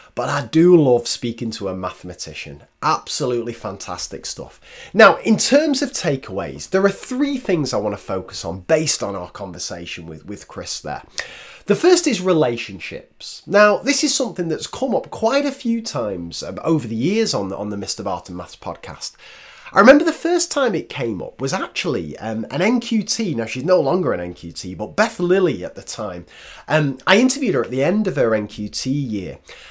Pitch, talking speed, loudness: 155 Hz, 195 wpm, -19 LUFS